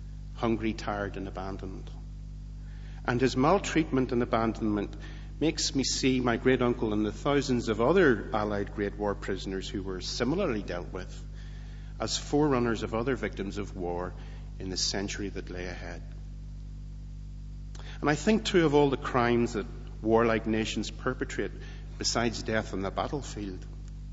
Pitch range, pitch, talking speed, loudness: 85-120 Hz, 105 Hz, 145 wpm, -29 LUFS